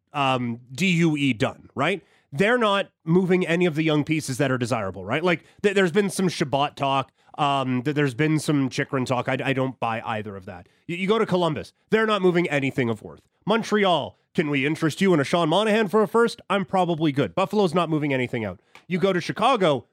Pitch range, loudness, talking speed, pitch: 135-185 Hz, -23 LUFS, 215 wpm, 155 Hz